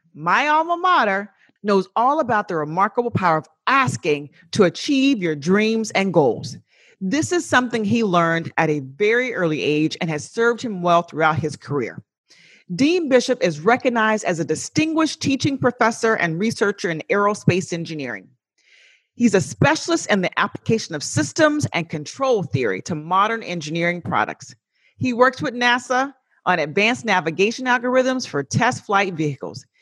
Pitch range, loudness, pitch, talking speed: 165-250 Hz, -20 LUFS, 200 Hz, 155 wpm